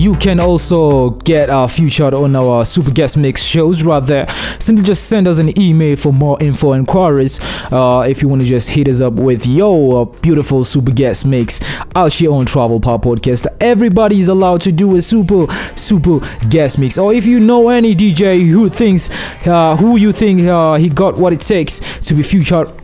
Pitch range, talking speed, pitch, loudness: 135-190 Hz, 200 wpm, 160 Hz, -11 LUFS